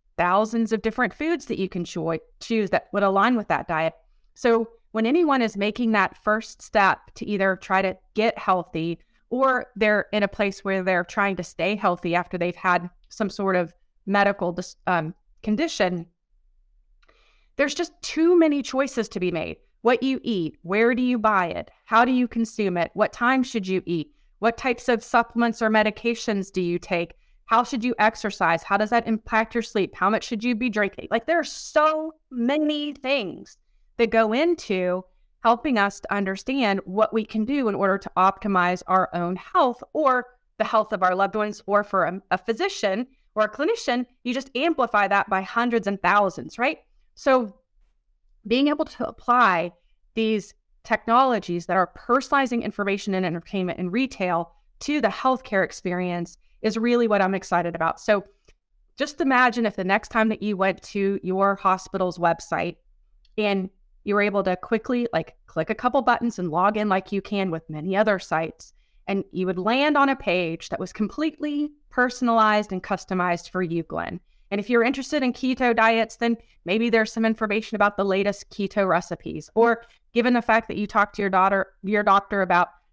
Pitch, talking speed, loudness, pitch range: 210 Hz, 185 wpm, -23 LUFS, 185-240 Hz